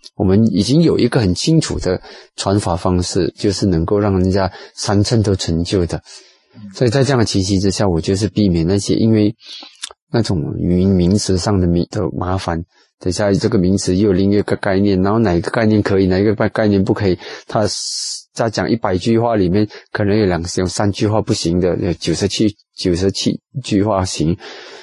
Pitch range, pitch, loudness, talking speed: 90-105 Hz, 100 Hz, -16 LUFS, 285 characters per minute